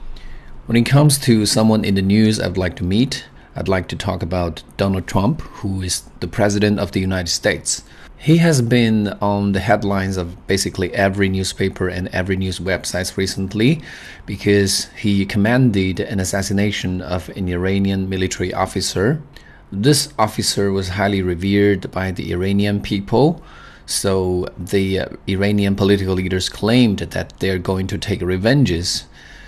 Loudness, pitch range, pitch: -18 LUFS, 90-105 Hz, 95 Hz